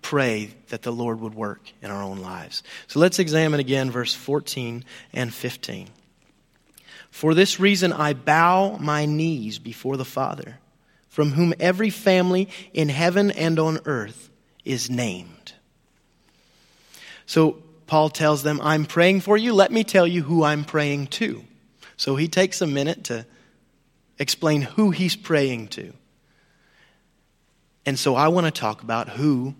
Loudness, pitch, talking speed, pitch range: -22 LUFS, 150 Hz, 150 wpm, 125-170 Hz